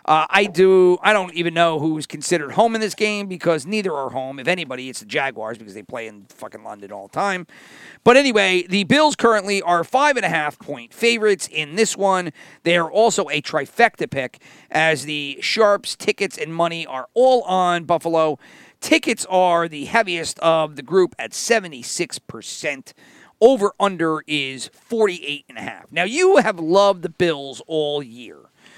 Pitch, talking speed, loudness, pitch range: 175 Hz, 175 wpm, -19 LUFS, 150-205 Hz